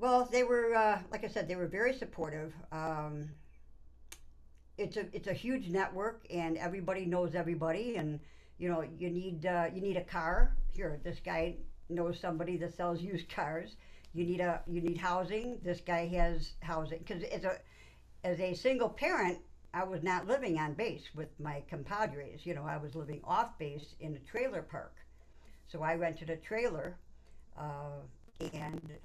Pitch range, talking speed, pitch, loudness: 155-190 Hz, 175 wpm, 170 Hz, -37 LUFS